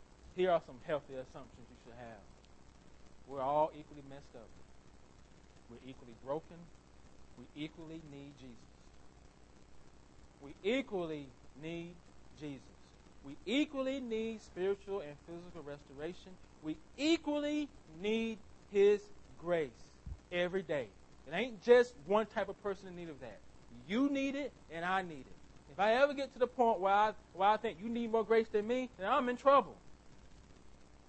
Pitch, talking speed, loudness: 170 Hz, 150 wpm, -35 LUFS